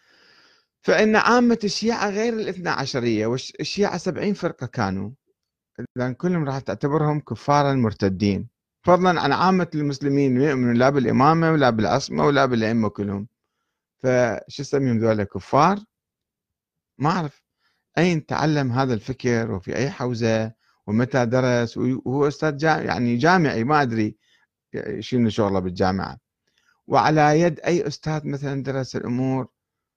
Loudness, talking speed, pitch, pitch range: -21 LUFS, 120 wpm, 130 Hz, 115-155 Hz